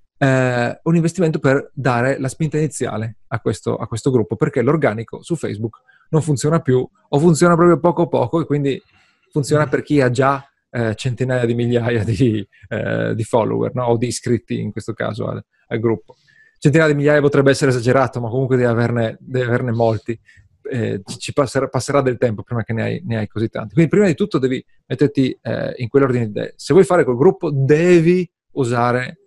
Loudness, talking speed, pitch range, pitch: -18 LUFS, 190 wpm, 120-150 Hz, 130 Hz